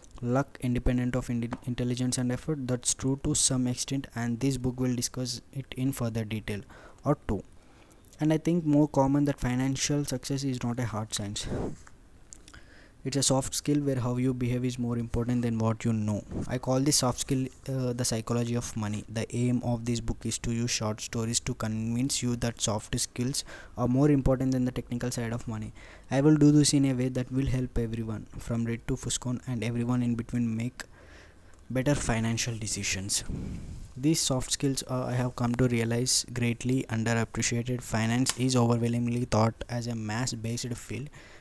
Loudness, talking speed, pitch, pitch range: -29 LUFS, 185 wpm, 120 Hz, 115-130 Hz